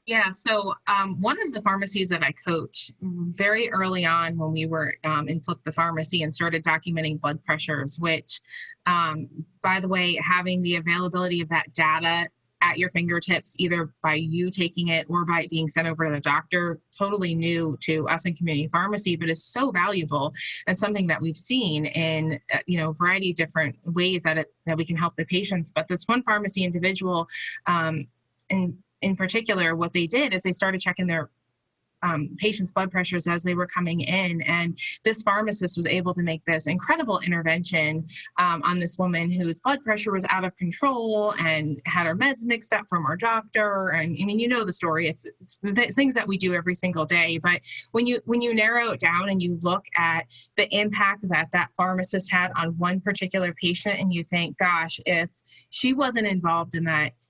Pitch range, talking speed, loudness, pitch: 160-190 Hz, 200 wpm, -24 LUFS, 175 Hz